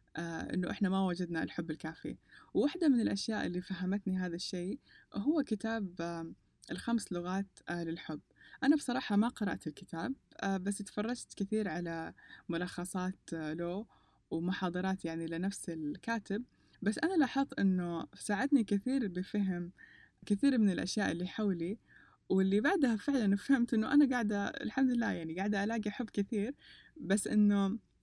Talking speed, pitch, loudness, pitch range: 140 wpm, 200 Hz, -35 LUFS, 175-225 Hz